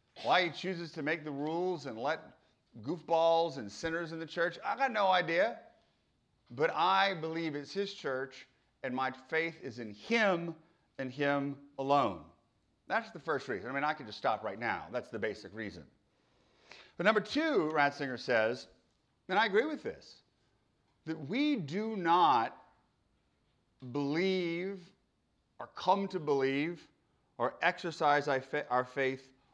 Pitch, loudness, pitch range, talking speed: 165 Hz, -33 LUFS, 140-185 Hz, 150 wpm